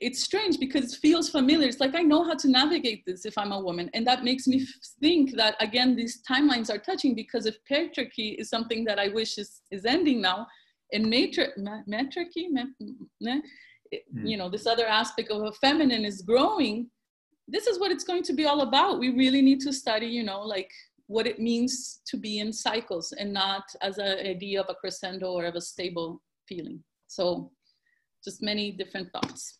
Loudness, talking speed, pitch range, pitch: -27 LUFS, 195 wpm, 210-280 Hz, 235 Hz